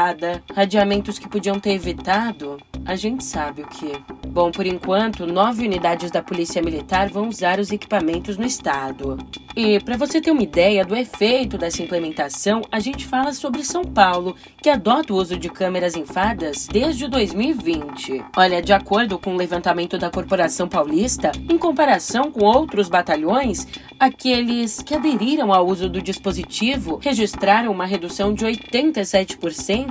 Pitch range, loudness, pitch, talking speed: 180-235 Hz, -20 LUFS, 200 Hz, 150 wpm